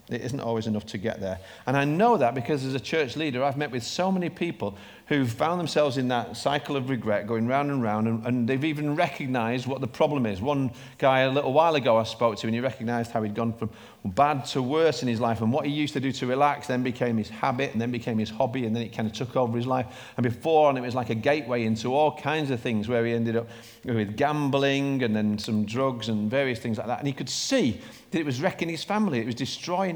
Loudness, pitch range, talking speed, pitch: -26 LUFS, 115-145 Hz, 265 wpm, 130 Hz